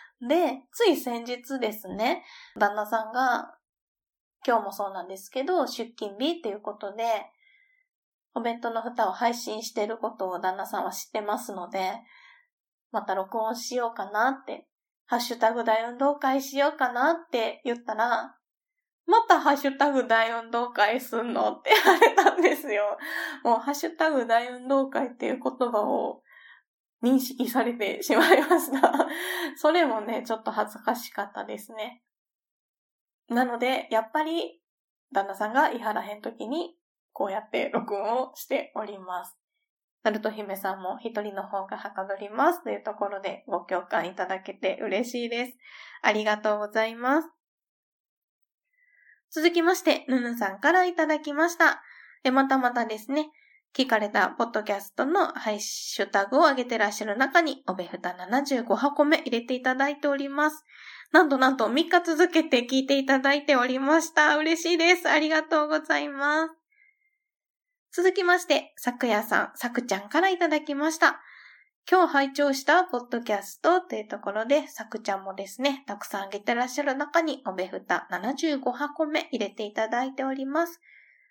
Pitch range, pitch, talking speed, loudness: 215-310 Hz, 255 Hz, 325 characters per minute, -26 LUFS